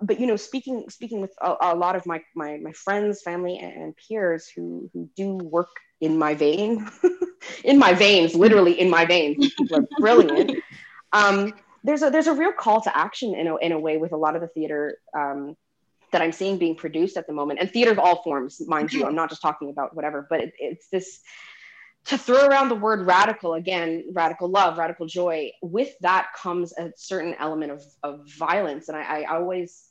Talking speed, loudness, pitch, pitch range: 205 wpm, -22 LUFS, 175 Hz, 160-205 Hz